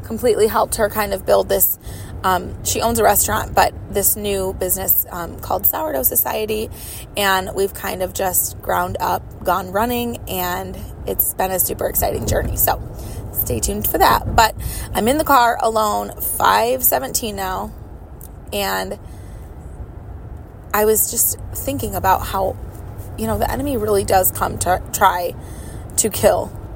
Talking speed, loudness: 150 wpm, -18 LUFS